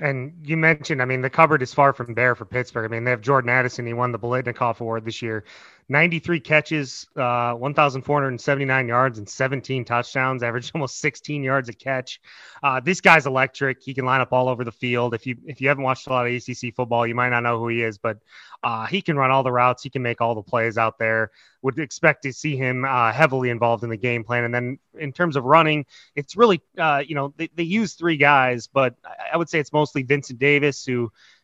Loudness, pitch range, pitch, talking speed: -21 LUFS, 120-145 Hz, 130 Hz, 235 wpm